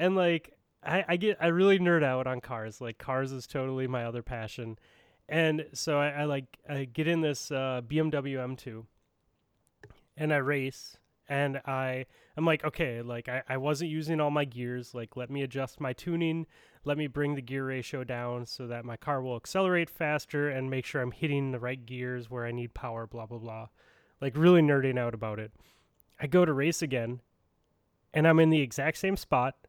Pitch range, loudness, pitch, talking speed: 120-155 Hz, -30 LUFS, 135 Hz, 200 wpm